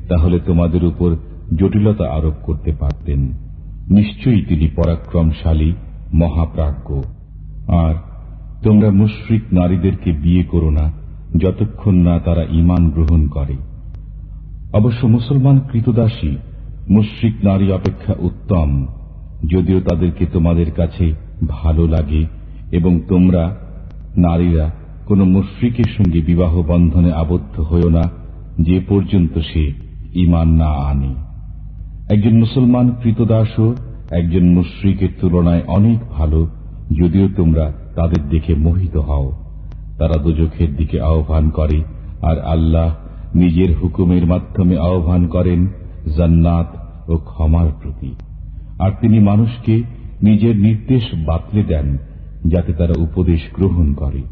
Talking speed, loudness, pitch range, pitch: 105 wpm, -15 LUFS, 80-95 Hz, 85 Hz